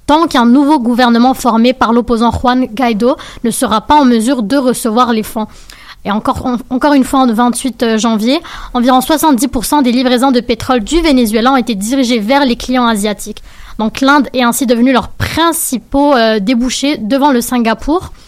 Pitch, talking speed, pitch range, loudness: 250 Hz, 175 wpm, 235-275 Hz, -11 LUFS